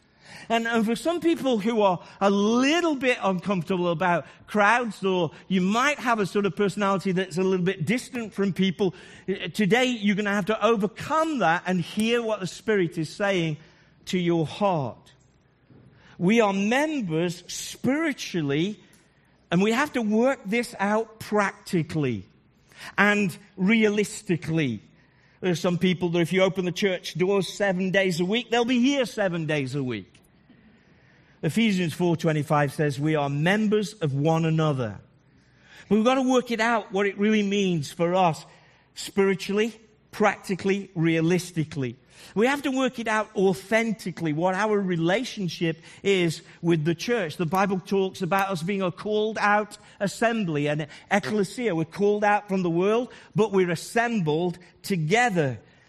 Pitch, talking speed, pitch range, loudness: 195 Hz, 155 wpm, 170-215 Hz, -25 LUFS